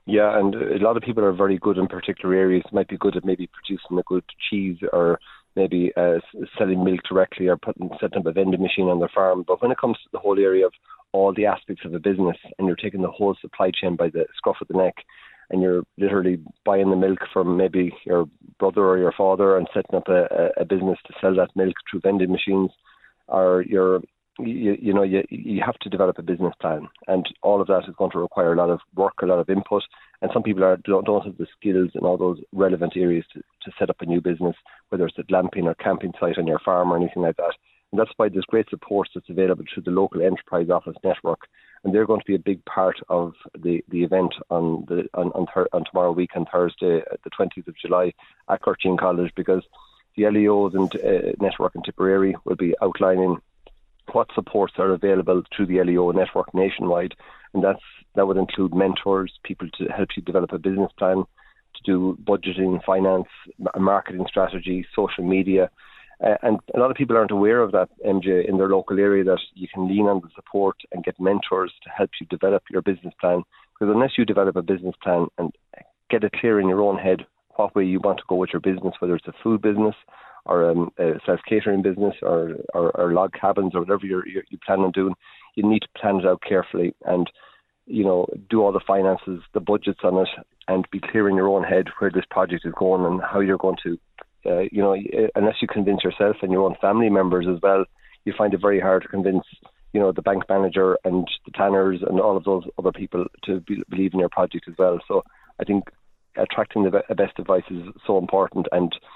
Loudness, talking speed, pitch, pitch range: -22 LUFS, 225 wpm, 95 Hz, 90-100 Hz